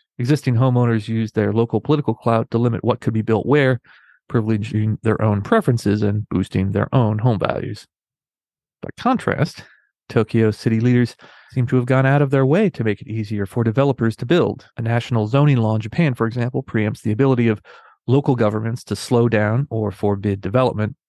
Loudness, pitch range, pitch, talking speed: -19 LUFS, 110-130 Hz, 115 Hz, 185 wpm